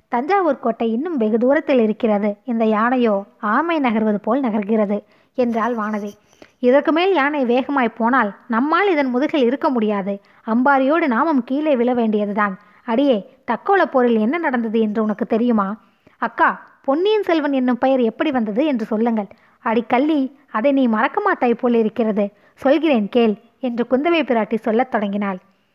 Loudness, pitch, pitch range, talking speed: -18 LUFS, 240 Hz, 220-275 Hz, 140 wpm